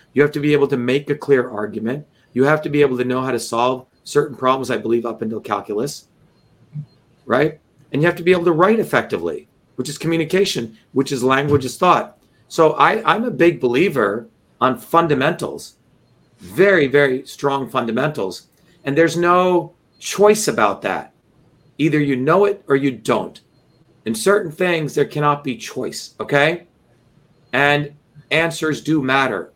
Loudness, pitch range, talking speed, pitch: -18 LUFS, 130-165 Hz, 165 wpm, 145 Hz